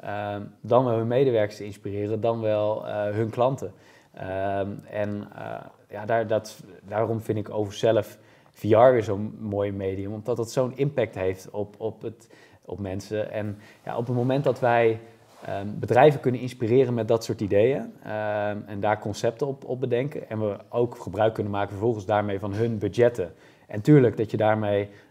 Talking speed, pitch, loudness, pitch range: 180 wpm, 110 Hz, -25 LUFS, 105-115 Hz